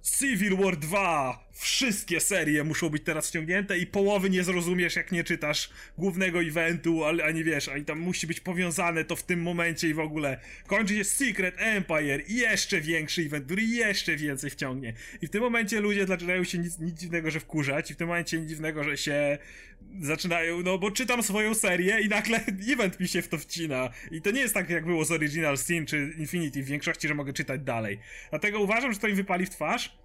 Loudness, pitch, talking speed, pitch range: -28 LUFS, 170 Hz, 210 wpm, 155-195 Hz